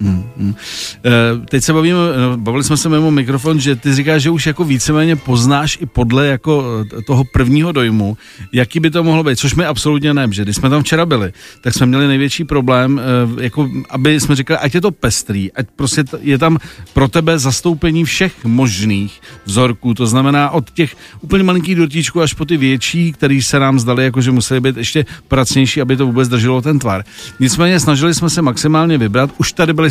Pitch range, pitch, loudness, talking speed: 125-160 Hz, 140 Hz, -13 LUFS, 195 wpm